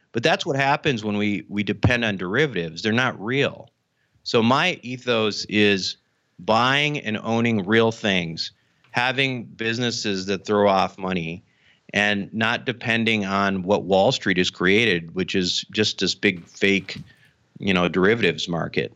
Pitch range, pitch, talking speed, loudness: 95-115 Hz, 105 Hz, 150 wpm, -21 LUFS